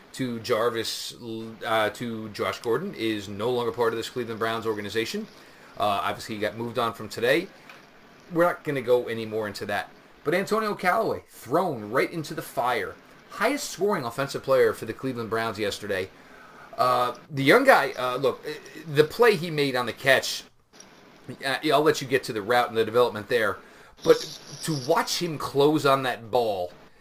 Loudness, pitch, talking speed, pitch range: -25 LUFS, 125 Hz, 180 wpm, 115-165 Hz